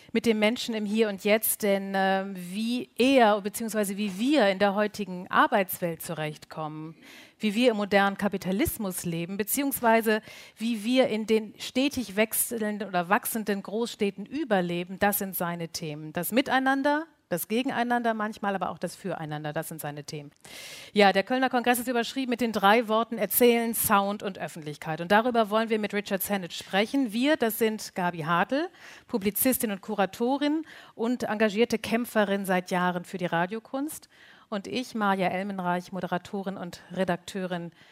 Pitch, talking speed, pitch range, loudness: 210 Hz, 155 wpm, 185-235 Hz, -27 LUFS